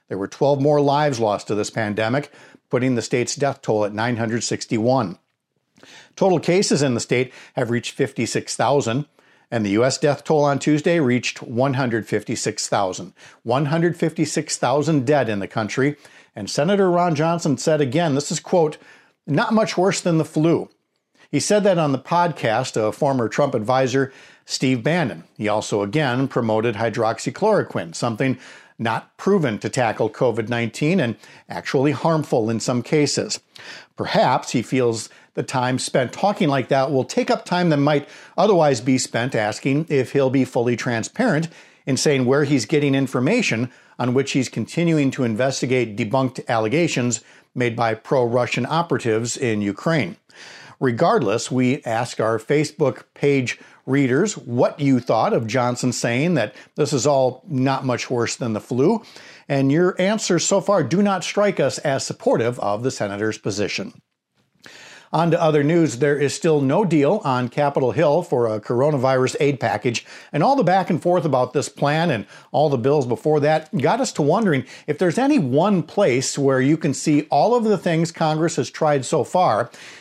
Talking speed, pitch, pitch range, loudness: 165 wpm, 140 Hz, 125-160 Hz, -20 LUFS